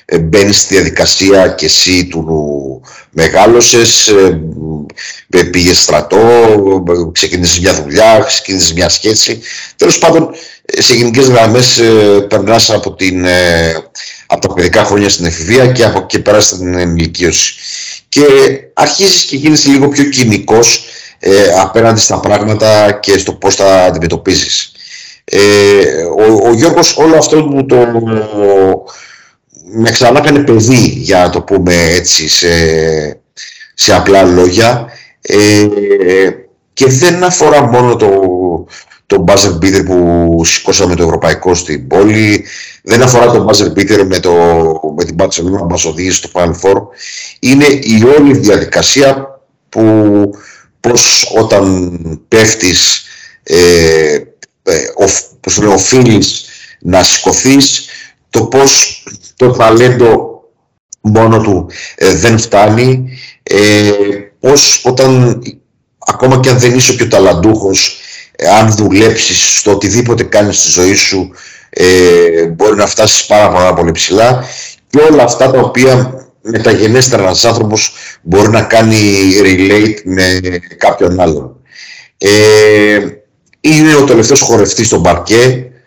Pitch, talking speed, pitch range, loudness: 105 Hz, 120 wpm, 90-125 Hz, -7 LUFS